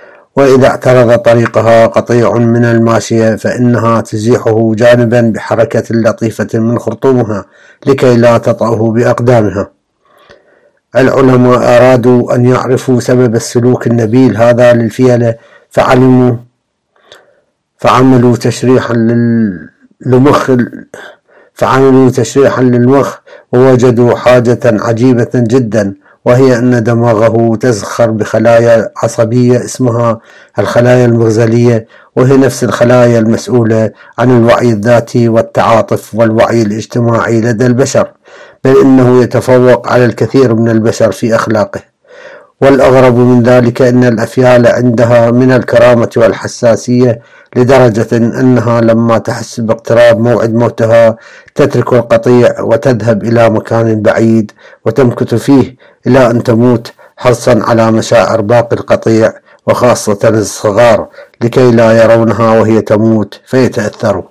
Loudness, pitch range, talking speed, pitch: -8 LUFS, 115-125 Hz, 100 wpm, 120 Hz